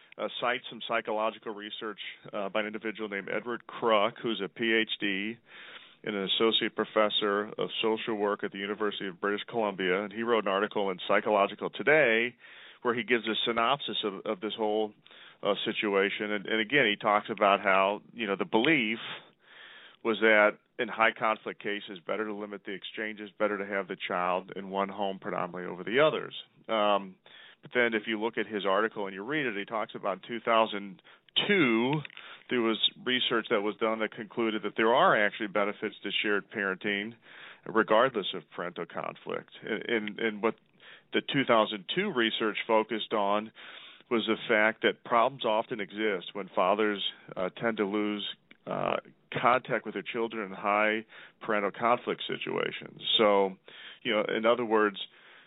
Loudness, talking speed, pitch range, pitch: -29 LUFS, 170 wpm, 100-115 Hz, 110 Hz